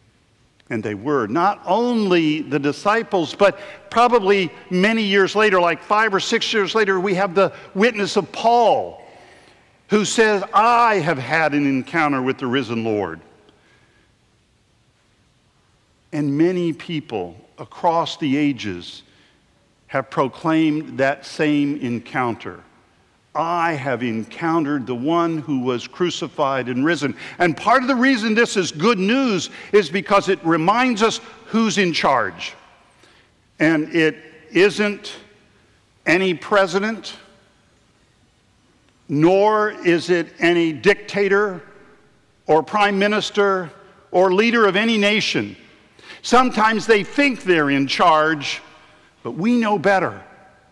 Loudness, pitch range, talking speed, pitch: -18 LUFS, 140-205 Hz, 120 wpm, 170 Hz